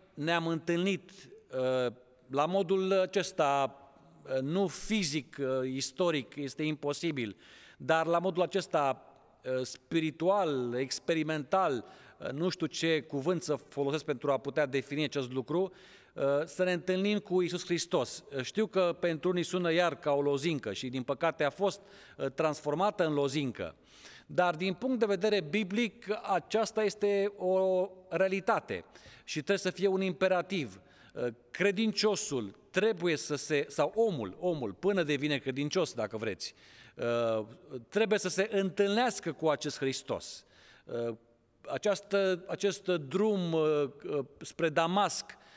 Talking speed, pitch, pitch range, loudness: 120 wpm, 165 Hz, 140-190 Hz, -32 LUFS